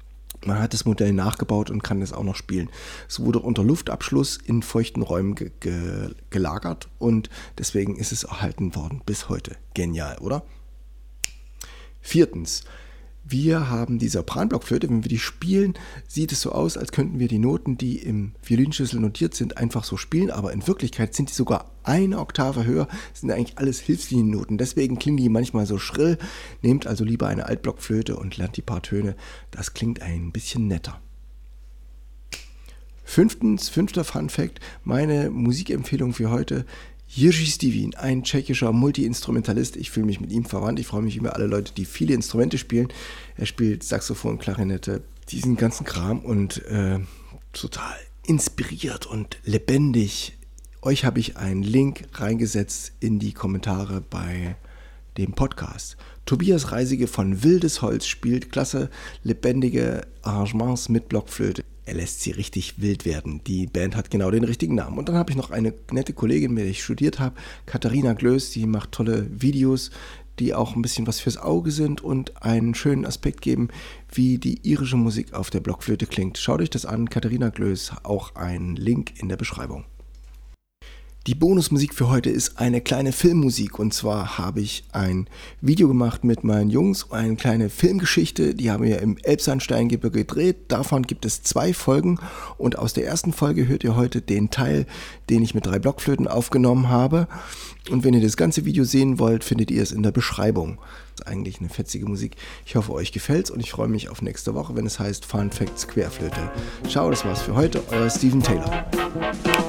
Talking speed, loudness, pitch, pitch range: 175 wpm, -23 LUFS, 115 Hz, 100-130 Hz